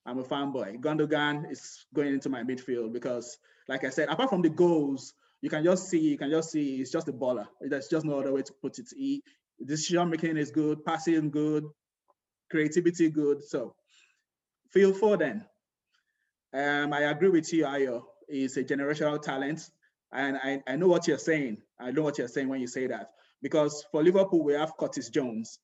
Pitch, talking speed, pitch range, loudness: 150 Hz, 195 wpm, 140-165 Hz, -29 LUFS